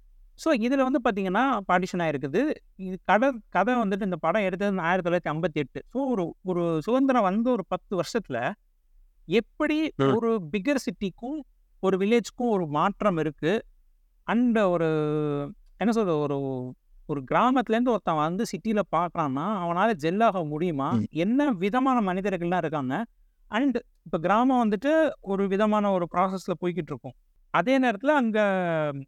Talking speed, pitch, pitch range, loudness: 130 wpm, 195 Hz, 165-235 Hz, -26 LUFS